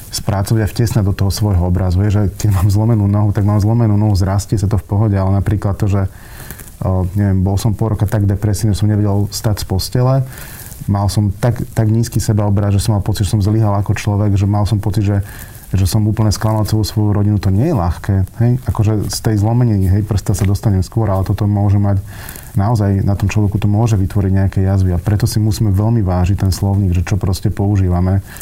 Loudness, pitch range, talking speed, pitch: -15 LUFS, 100-110 Hz, 225 wpm, 105 Hz